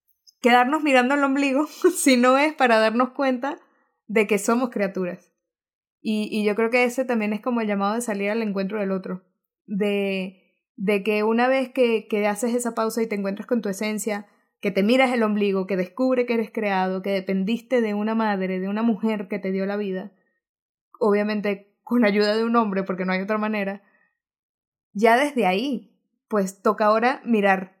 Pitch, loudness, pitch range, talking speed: 215 Hz, -22 LUFS, 200-240 Hz, 190 wpm